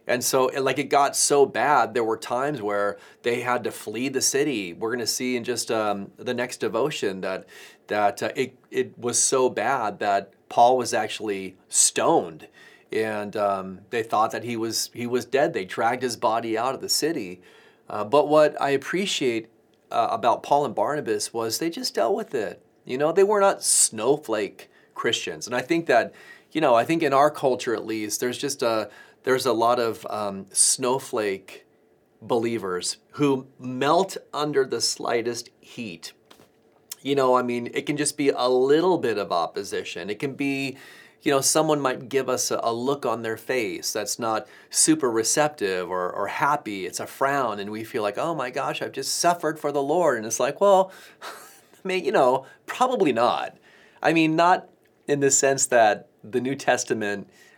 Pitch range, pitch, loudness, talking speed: 115-150 Hz, 130 Hz, -23 LUFS, 190 wpm